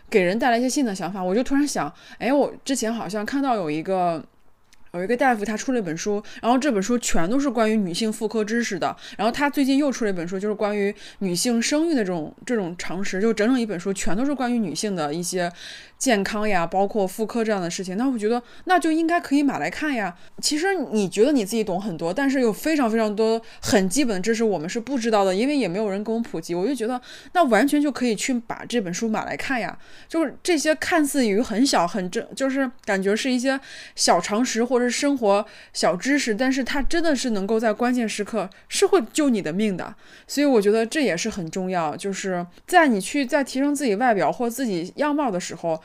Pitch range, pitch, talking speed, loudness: 200-270 Hz, 225 Hz, 345 characters per minute, -23 LUFS